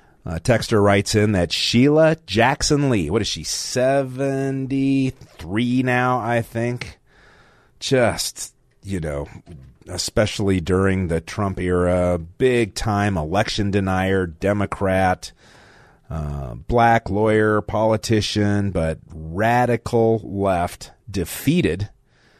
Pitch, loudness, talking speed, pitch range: 105 Hz, -20 LUFS, 95 wpm, 95-120 Hz